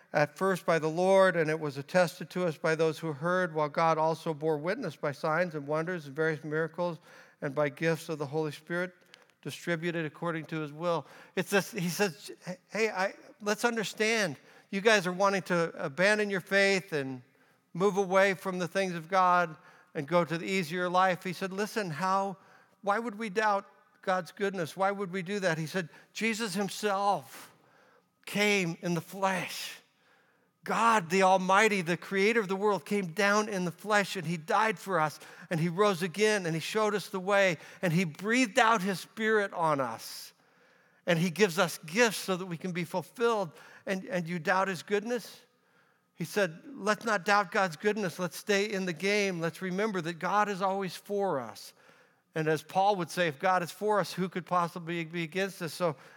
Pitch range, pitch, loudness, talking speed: 170-205 Hz, 185 Hz, -30 LUFS, 195 wpm